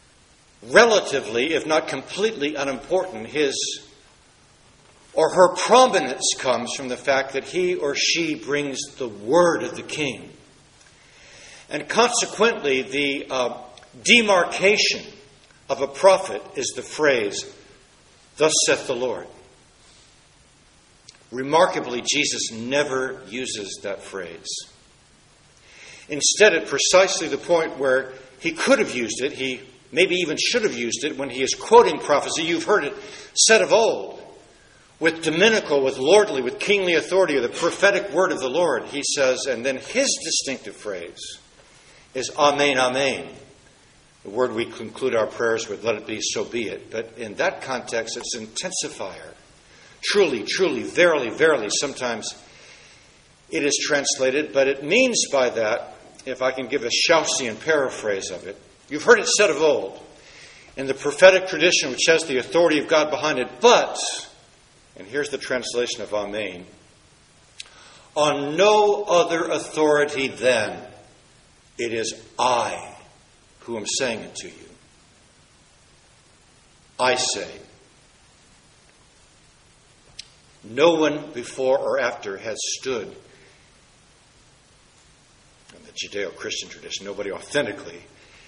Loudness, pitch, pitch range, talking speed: -21 LUFS, 150 Hz, 135-210 Hz, 130 wpm